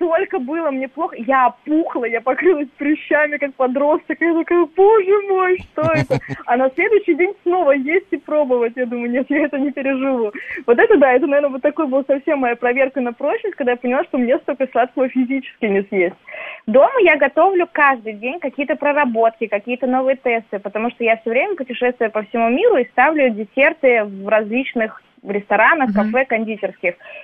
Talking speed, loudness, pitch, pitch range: 180 wpm, -17 LUFS, 270 Hz, 240-315 Hz